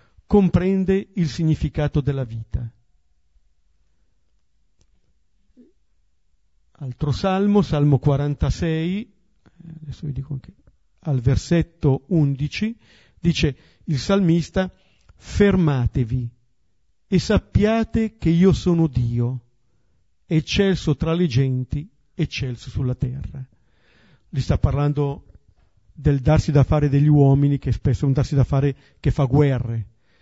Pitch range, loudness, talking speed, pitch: 120-160 Hz, -21 LUFS, 105 wpm, 140 Hz